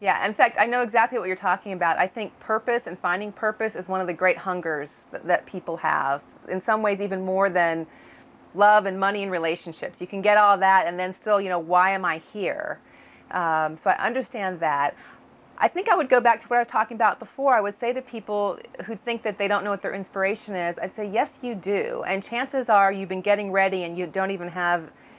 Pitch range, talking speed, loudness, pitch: 180-215 Hz, 240 wpm, -24 LUFS, 195 Hz